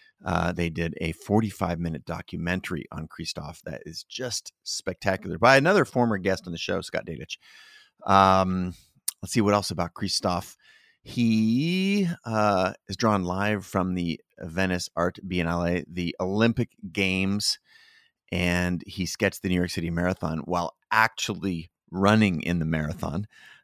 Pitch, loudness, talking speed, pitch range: 95 Hz, -26 LUFS, 140 wpm, 85-105 Hz